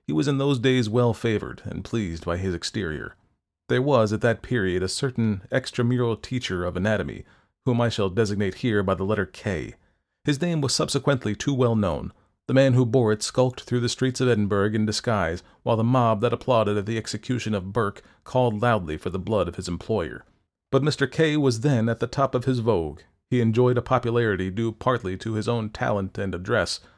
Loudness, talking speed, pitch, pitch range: -24 LUFS, 205 wpm, 115 Hz, 105-125 Hz